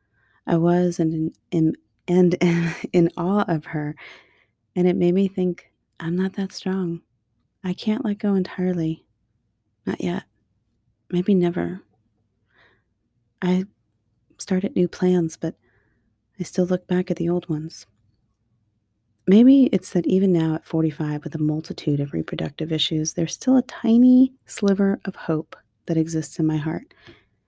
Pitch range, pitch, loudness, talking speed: 115-185 Hz, 165 Hz, -22 LUFS, 150 wpm